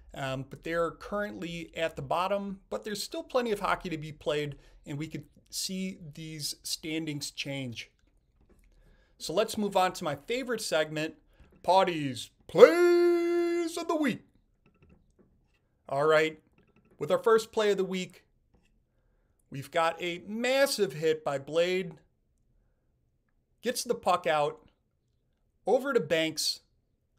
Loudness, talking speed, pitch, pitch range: -29 LUFS, 130 wpm, 165 Hz, 150-210 Hz